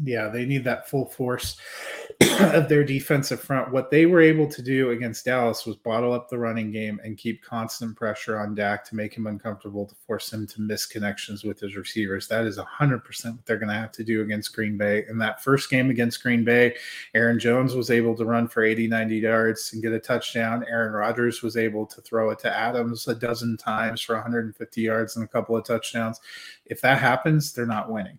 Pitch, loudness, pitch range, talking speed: 115 Hz, -24 LUFS, 110-120 Hz, 220 wpm